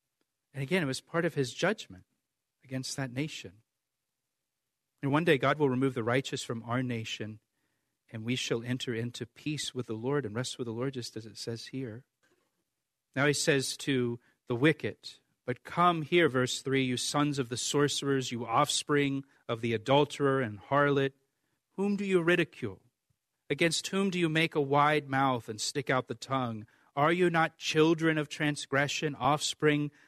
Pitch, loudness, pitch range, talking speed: 135 Hz, -30 LUFS, 125-150 Hz, 175 wpm